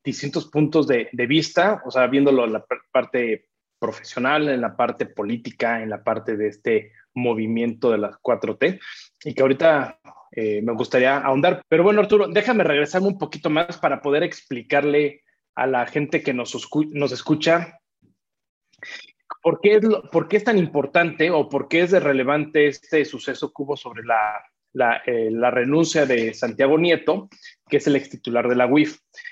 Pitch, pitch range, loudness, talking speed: 145 Hz, 125-165 Hz, -21 LUFS, 180 wpm